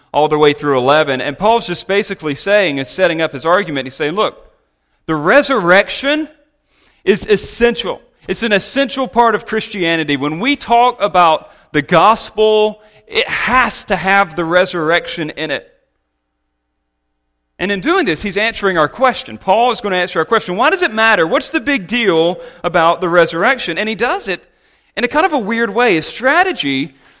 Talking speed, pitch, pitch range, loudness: 180 wpm, 195 Hz, 155-235 Hz, -14 LUFS